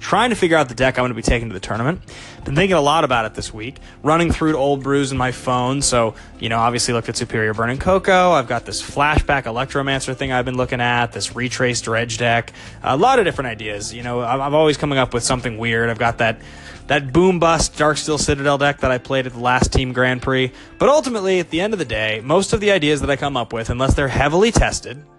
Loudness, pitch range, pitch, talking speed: -18 LUFS, 115-145 Hz, 125 Hz, 255 wpm